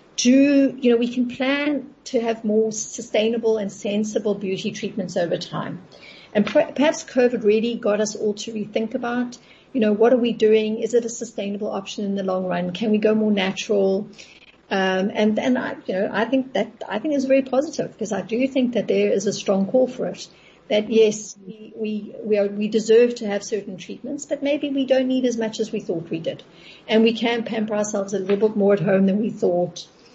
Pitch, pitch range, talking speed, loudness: 220 Hz, 205-245 Hz, 220 wpm, -22 LUFS